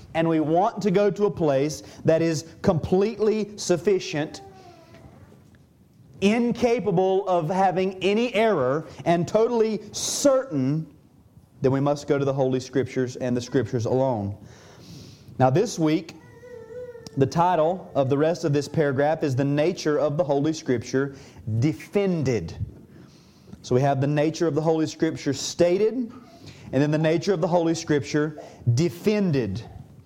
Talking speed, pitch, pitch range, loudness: 140 wpm, 155 Hz, 135-185 Hz, -23 LUFS